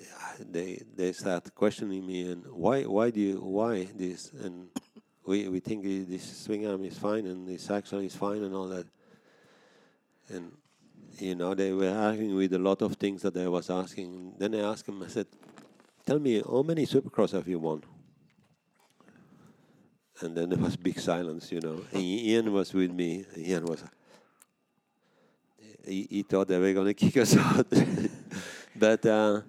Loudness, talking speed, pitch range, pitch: -30 LUFS, 170 wpm, 90-100 Hz, 95 Hz